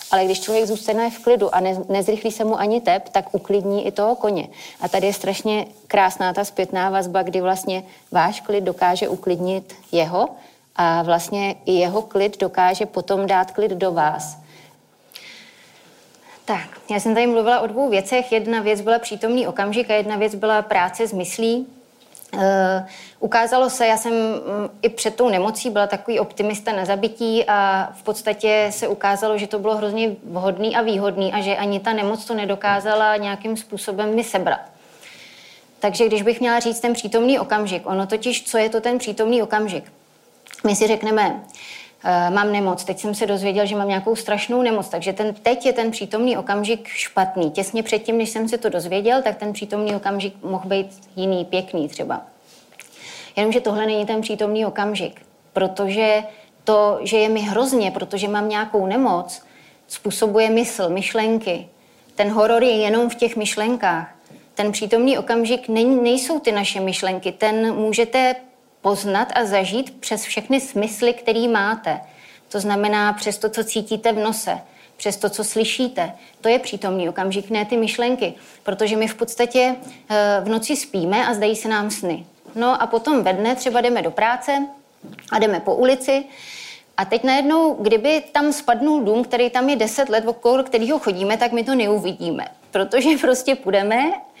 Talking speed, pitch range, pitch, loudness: 170 wpm, 200-235 Hz, 215 Hz, -20 LUFS